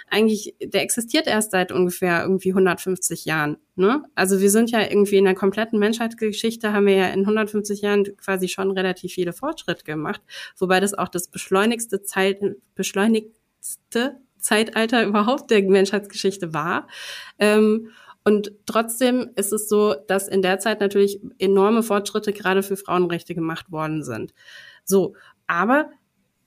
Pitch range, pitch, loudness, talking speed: 190-215 Hz, 200 Hz, -21 LUFS, 145 wpm